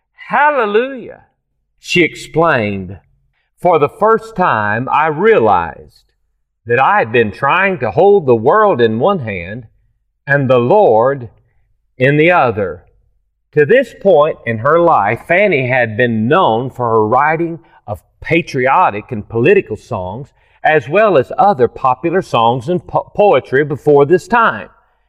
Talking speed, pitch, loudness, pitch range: 135 wpm, 140 Hz, -12 LUFS, 115-190 Hz